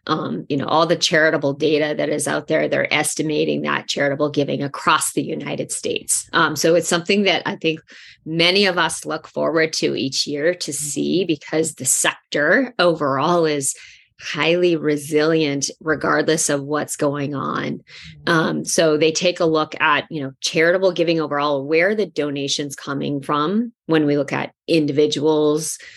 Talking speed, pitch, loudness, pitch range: 165 wpm, 155 Hz, -19 LUFS, 145-165 Hz